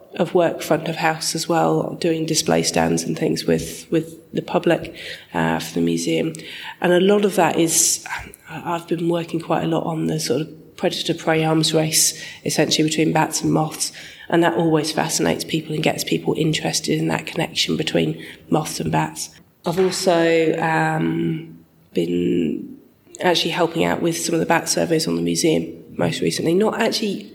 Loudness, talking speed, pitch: -20 LUFS, 180 wpm, 160 Hz